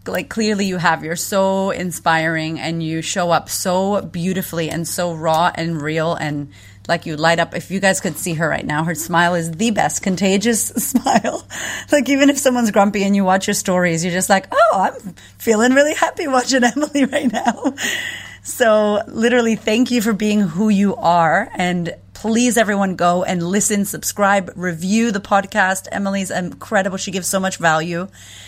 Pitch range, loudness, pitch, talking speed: 170-215 Hz, -17 LUFS, 195 Hz, 180 wpm